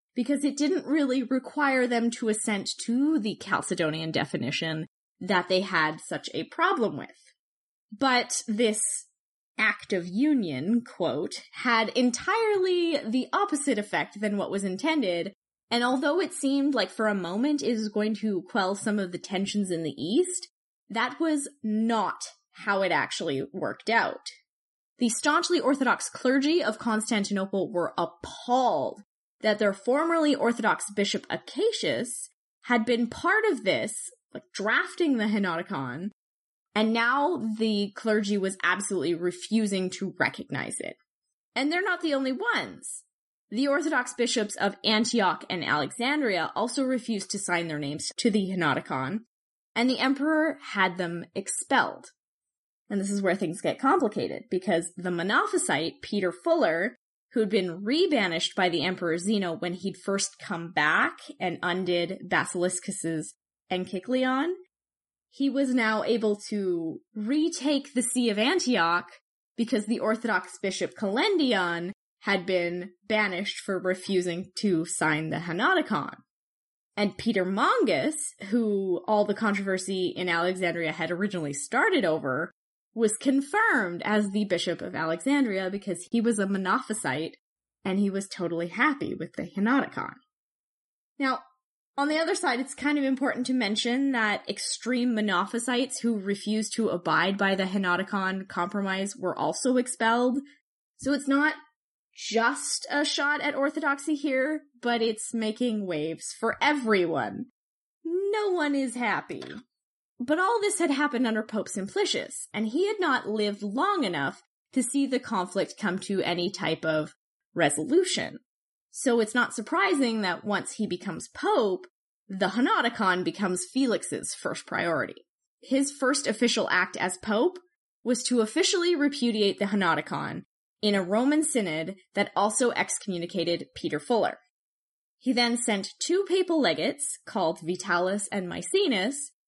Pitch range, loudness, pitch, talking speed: 190-275 Hz, -27 LUFS, 220 Hz, 140 wpm